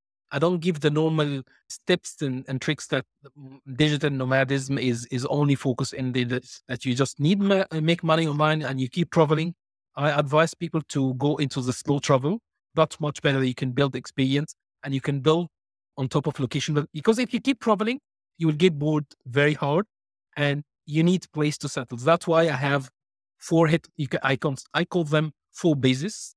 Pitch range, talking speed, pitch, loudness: 135-165 Hz, 190 wpm, 150 Hz, -25 LUFS